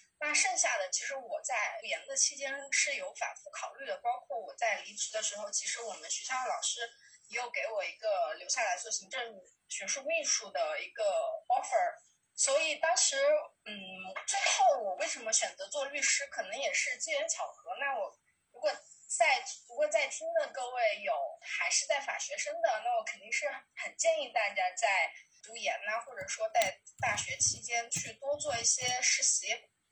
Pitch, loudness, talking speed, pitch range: 310 Hz, -32 LUFS, 275 characters per minute, 275-340 Hz